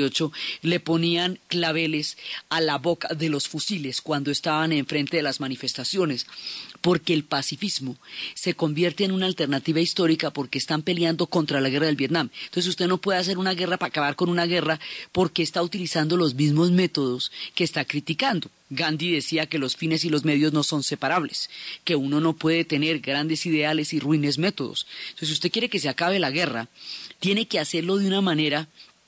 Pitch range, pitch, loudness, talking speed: 150-175 Hz, 160 Hz, -24 LUFS, 185 wpm